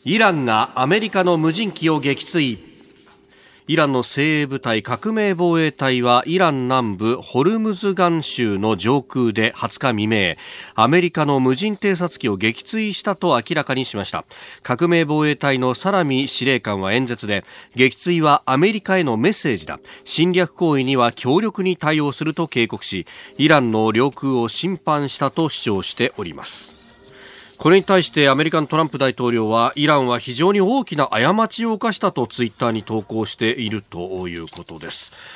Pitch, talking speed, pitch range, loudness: 140 Hz, 330 characters per minute, 120-175 Hz, -18 LUFS